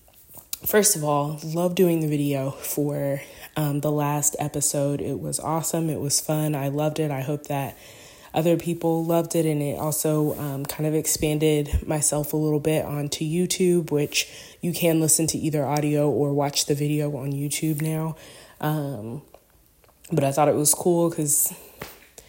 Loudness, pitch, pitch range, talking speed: -23 LUFS, 150 Hz, 145-160 Hz, 170 wpm